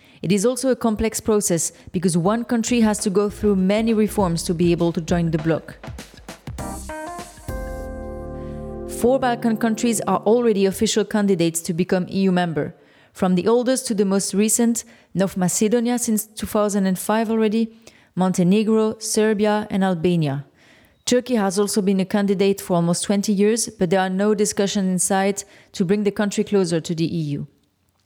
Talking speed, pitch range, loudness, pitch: 160 wpm, 180-220 Hz, -20 LUFS, 200 Hz